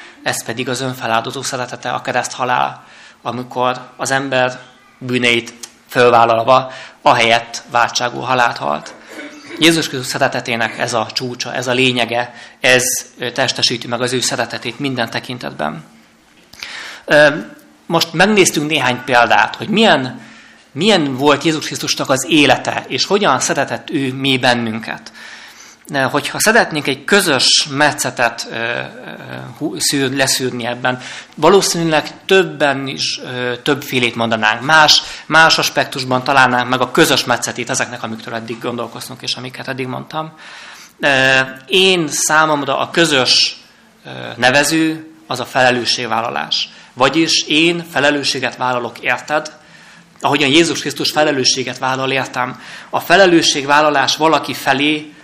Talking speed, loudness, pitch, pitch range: 115 wpm, -14 LUFS, 130 Hz, 120-150 Hz